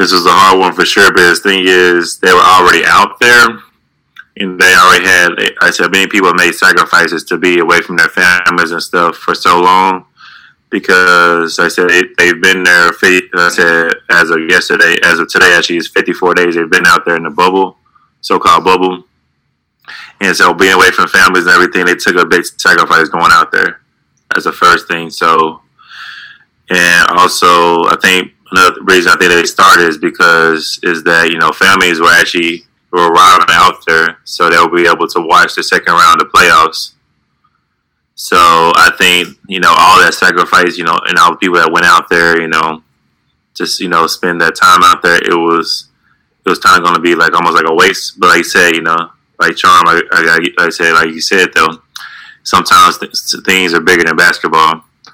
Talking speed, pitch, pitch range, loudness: 200 wpm, 85 Hz, 85-90 Hz, -7 LUFS